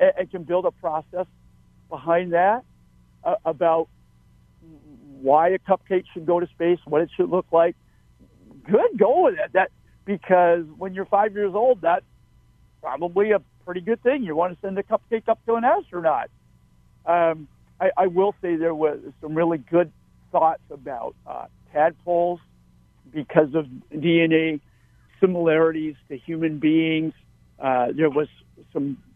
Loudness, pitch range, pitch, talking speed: -22 LUFS, 150-185 Hz, 165 Hz, 150 wpm